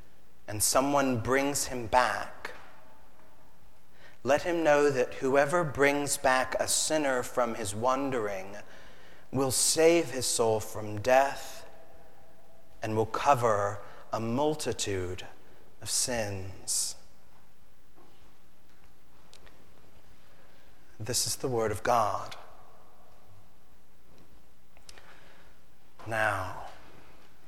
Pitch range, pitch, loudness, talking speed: 100-140 Hz, 125 Hz, -28 LUFS, 80 wpm